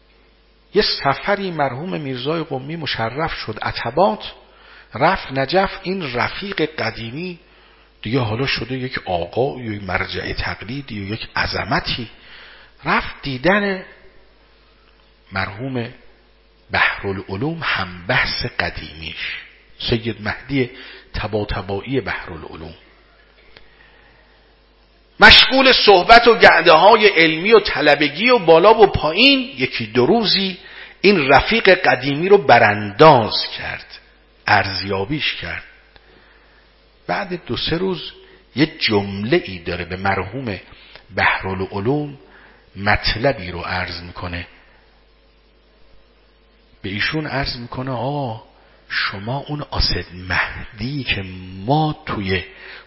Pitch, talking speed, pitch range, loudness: 130 Hz, 100 wpm, 100-160 Hz, -17 LUFS